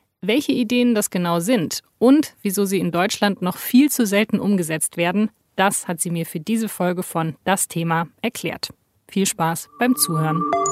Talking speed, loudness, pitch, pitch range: 175 wpm, -20 LUFS, 190 Hz, 170-225 Hz